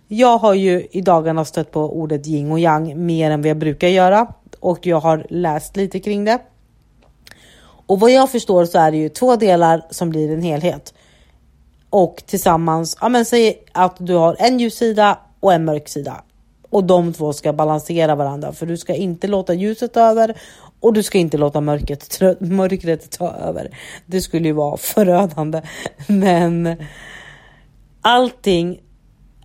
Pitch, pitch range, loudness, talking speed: 175 Hz, 155-195 Hz, -16 LUFS, 165 wpm